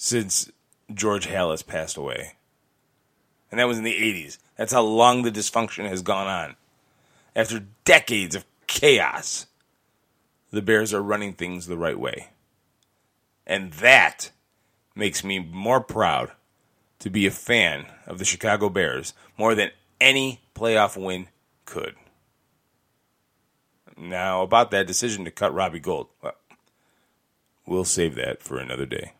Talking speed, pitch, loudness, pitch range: 135 wpm, 105 Hz, -22 LUFS, 95-115 Hz